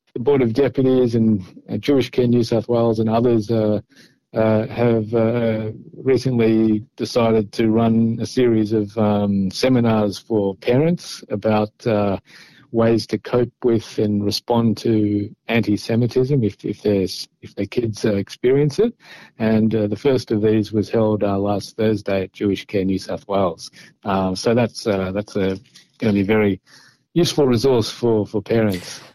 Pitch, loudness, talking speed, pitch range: 110 Hz, -19 LUFS, 160 wpm, 105-120 Hz